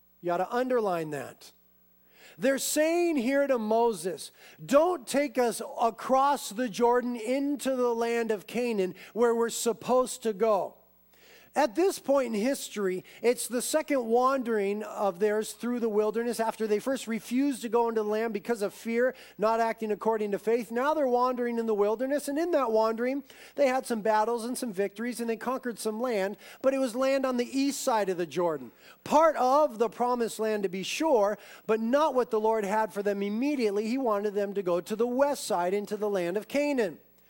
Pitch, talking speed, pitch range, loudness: 235 Hz, 195 wpm, 210-260 Hz, -28 LUFS